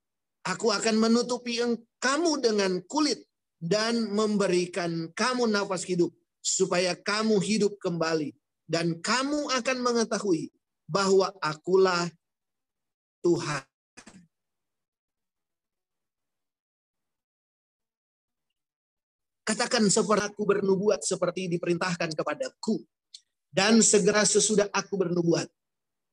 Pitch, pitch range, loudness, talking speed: 195 Hz, 175-220 Hz, -26 LUFS, 80 wpm